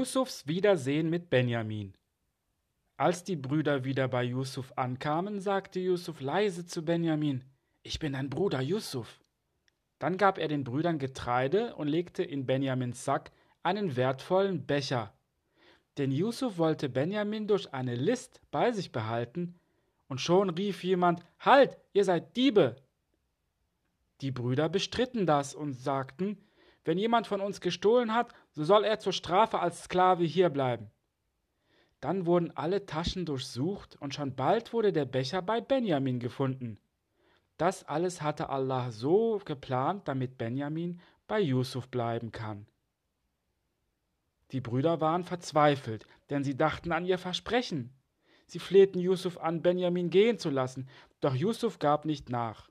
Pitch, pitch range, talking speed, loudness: 160 Hz, 130-185 Hz, 140 wpm, -30 LUFS